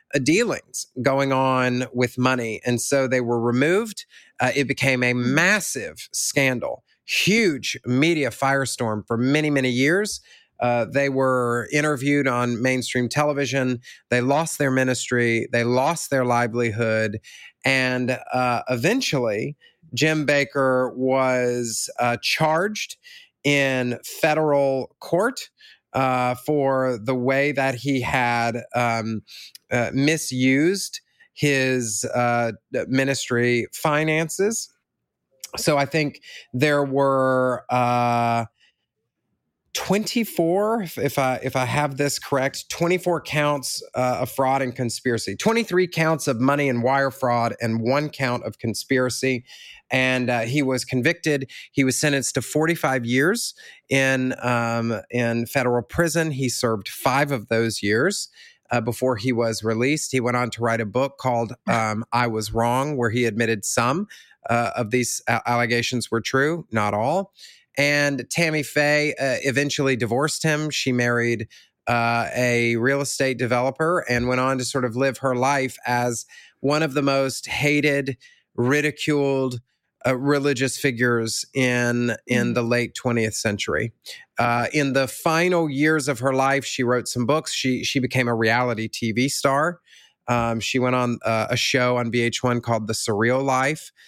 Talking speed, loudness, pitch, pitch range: 140 wpm, -22 LUFS, 130 Hz, 120-145 Hz